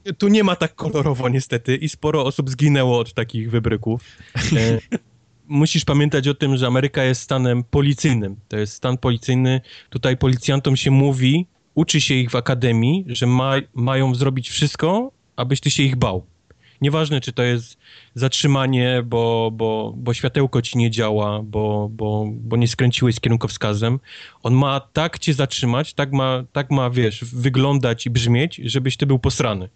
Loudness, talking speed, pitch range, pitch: -19 LUFS, 165 wpm, 120-140 Hz, 130 Hz